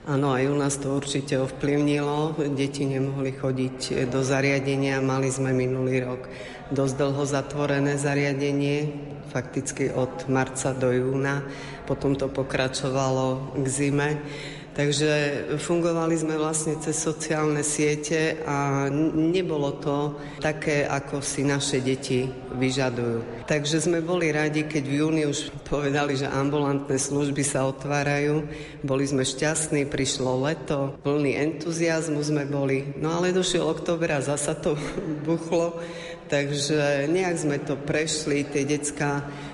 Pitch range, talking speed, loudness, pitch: 135-150 Hz, 125 wpm, -25 LUFS, 145 Hz